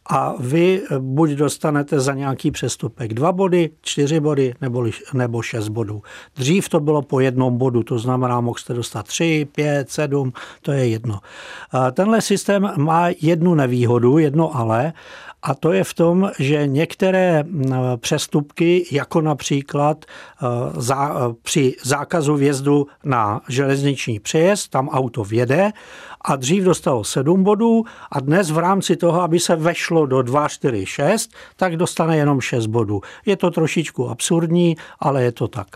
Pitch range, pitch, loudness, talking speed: 130-170 Hz, 145 Hz, -19 LUFS, 150 wpm